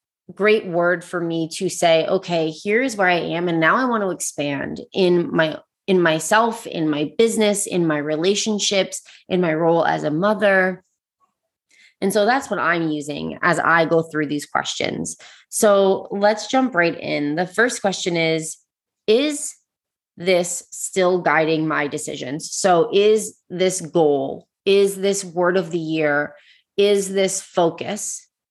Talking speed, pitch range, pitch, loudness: 155 wpm, 160-200 Hz, 180 Hz, -20 LUFS